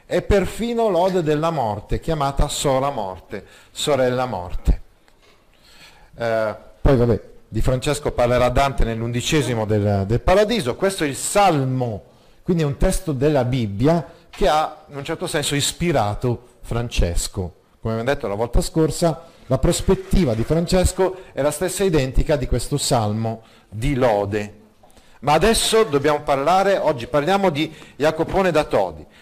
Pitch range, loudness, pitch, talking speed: 115-165 Hz, -20 LUFS, 140 Hz, 140 wpm